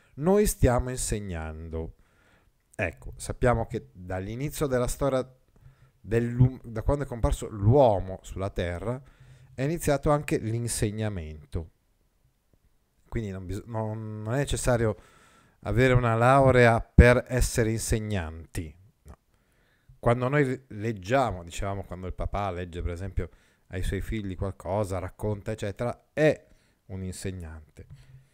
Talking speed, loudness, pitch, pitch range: 110 wpm, -27 LUFS, 110 Hz, 95-125 Hz